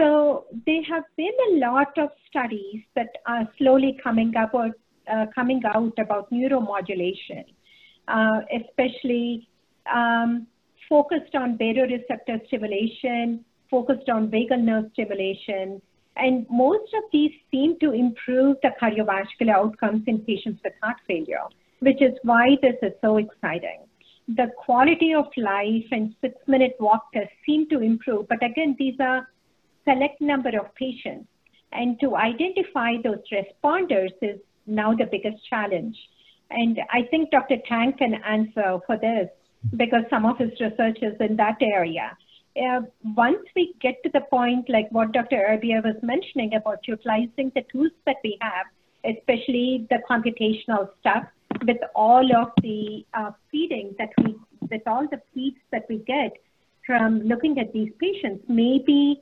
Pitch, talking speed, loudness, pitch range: 240 Hz, 150 wpm, -23 LUFS, 220-270 Hz